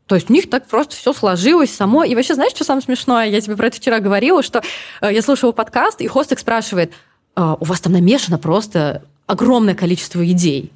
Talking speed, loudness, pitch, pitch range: 205 wpm, -15 LUFS, 220 Hz, 180-255 Hz